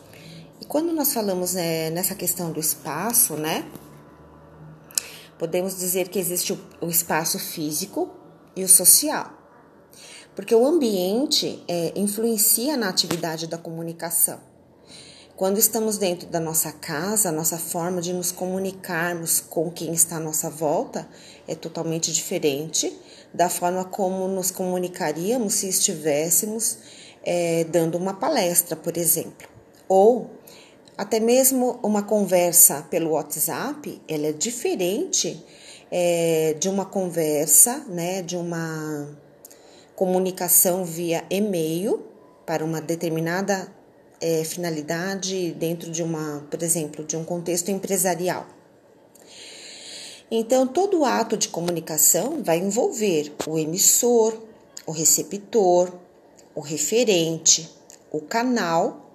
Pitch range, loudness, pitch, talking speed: 165-195 Hz, -21 LUFS, 175 Hz, 115 wpm